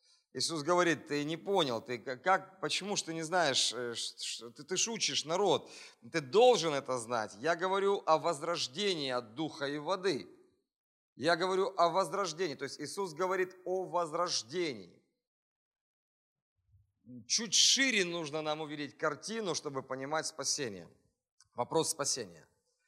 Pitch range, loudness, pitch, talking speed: 140-190 Hz, -33 LUFS, 165 Hz, 130 wpm